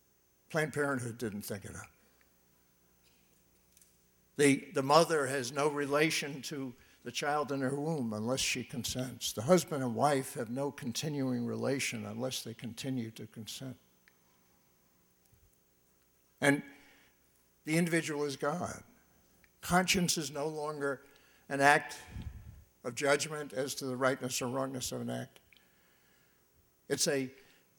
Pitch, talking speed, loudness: 125 Hz, 125 wpm, -33 LUFS